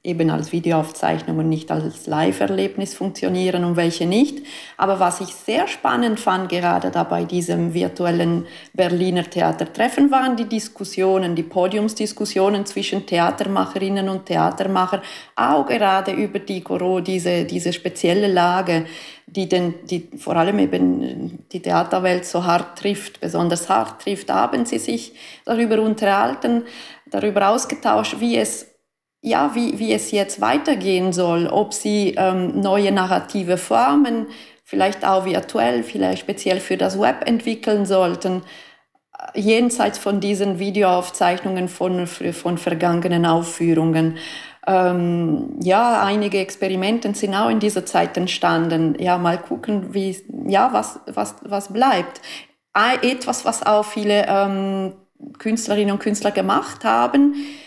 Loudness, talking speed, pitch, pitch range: -20 LUFS, 130 wpm, 190 Hz, 175-210 Hz